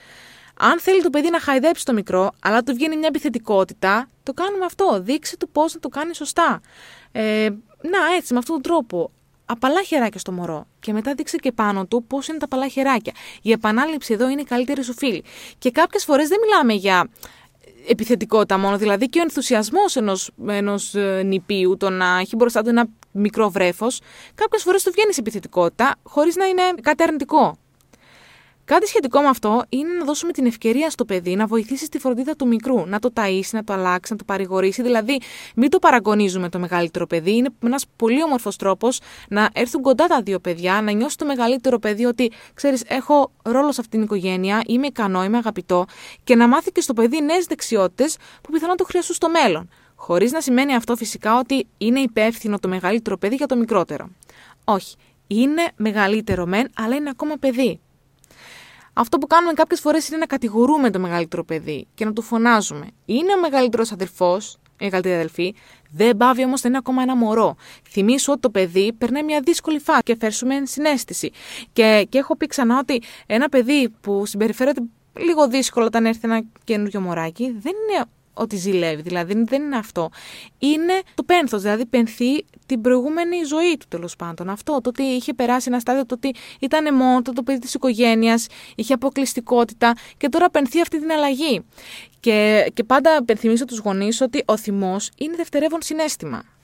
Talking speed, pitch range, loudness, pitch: 185 wpm, 210-295 Hz, -19 LUFS, 245 Hz